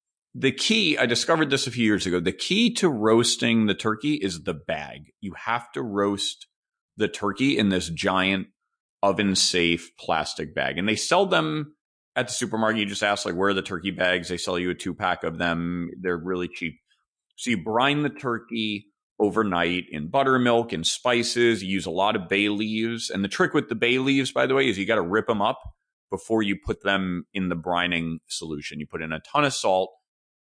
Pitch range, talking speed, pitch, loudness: 90-120 Hz, 210 wpm, 100 Hz, -24 LUFS